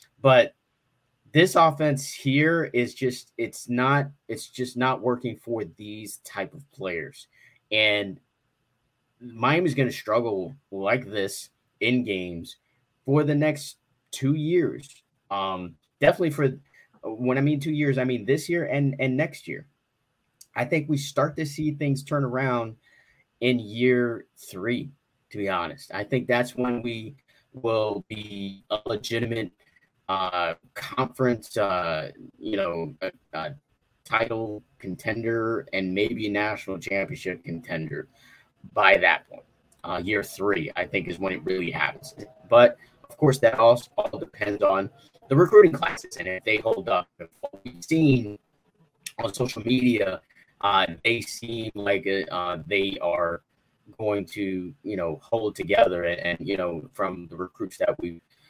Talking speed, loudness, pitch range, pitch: 145 wpm, -25 LUFS, 105-140 Hz, 125 Hz